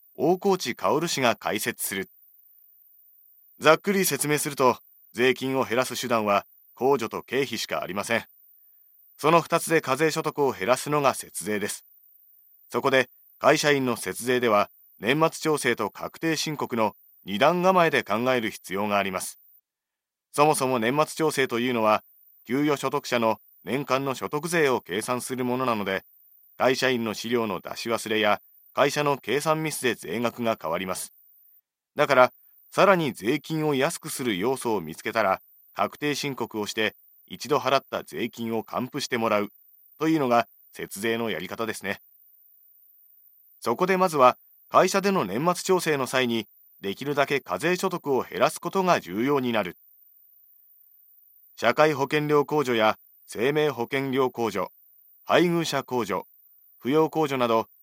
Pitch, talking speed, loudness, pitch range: 130 Hz, 285 characters per minute, -25 LUFS, 115-150 Hz